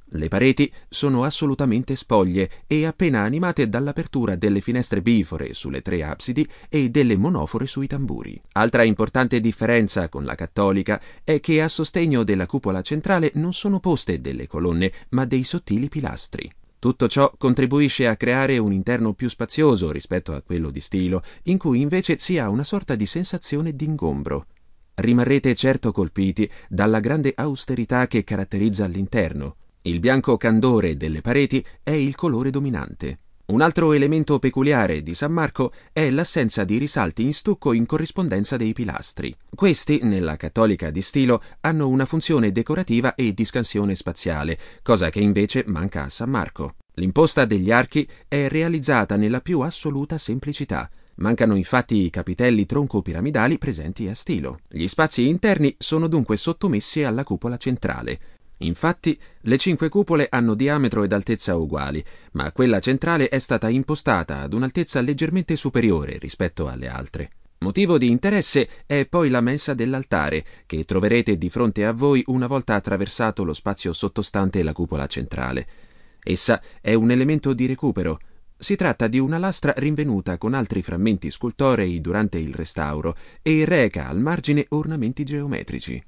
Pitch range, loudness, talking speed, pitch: 95-145 Hz, -21 LUFS, 150 wpm, 120 Hz